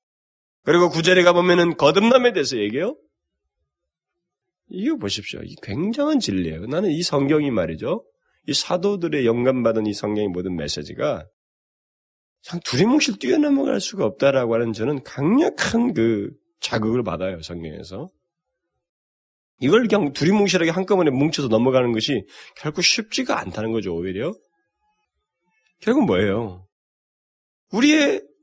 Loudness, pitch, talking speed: -20 LUFS, 150 Hz, 295 characters per minute